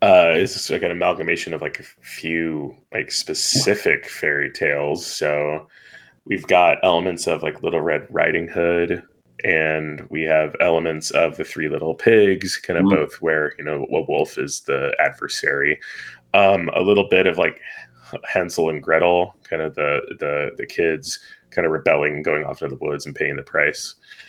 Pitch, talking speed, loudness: 100 Hz, 175 wpm, -20 LUFS